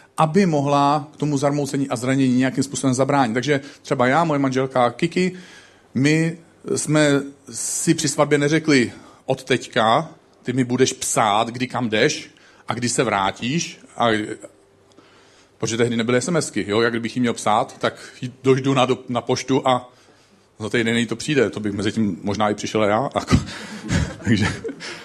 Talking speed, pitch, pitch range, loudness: 160 wpm, 130 Hz, 120-145 Hz, -20 LUFS